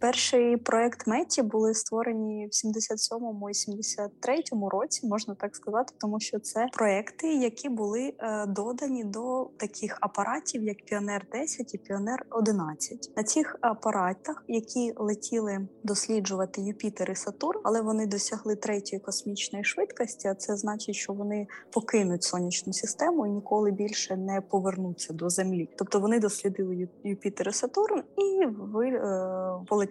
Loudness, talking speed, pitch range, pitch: -30 LUFS, 140 wpm, 200-235 Hz, 215 Hz